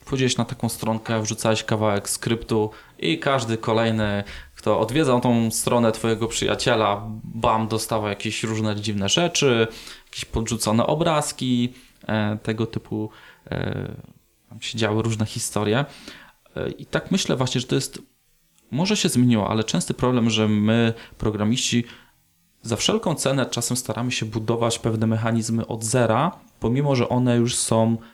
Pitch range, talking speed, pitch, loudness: 110-125 Hz, 135 wpm, 115 Hz, -22 LUFS